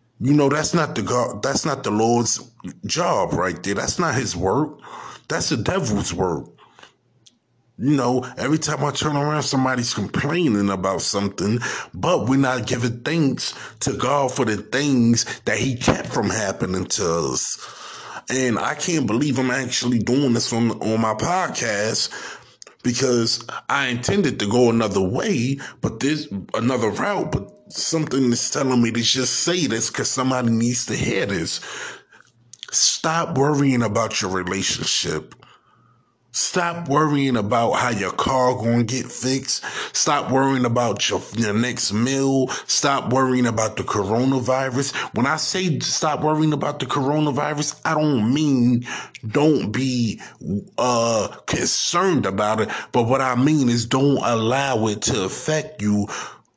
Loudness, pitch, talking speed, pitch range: -21 LUFS, 125 Hz, 150 wpm, 115-140 Hz